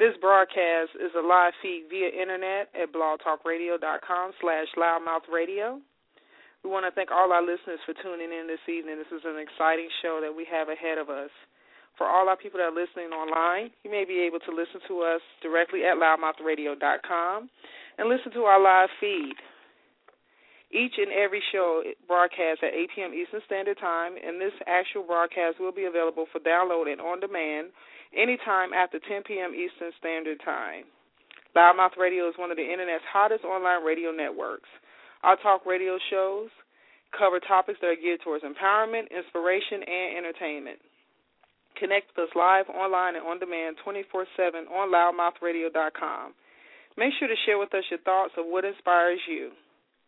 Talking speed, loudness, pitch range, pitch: 165 wpm, -26 LUFS, 165-195 Hz, 180 Hz